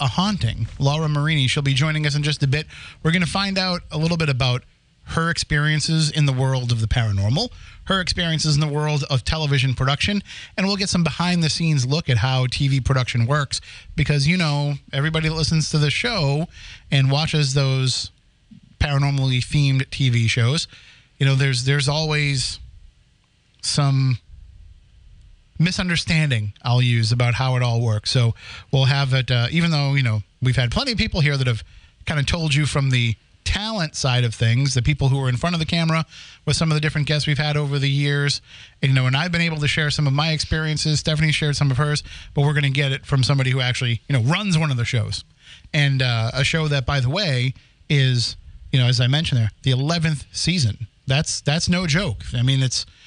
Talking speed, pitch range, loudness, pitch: 205 wpm, 125-155 Hz, -20 LUFS, 140 Hz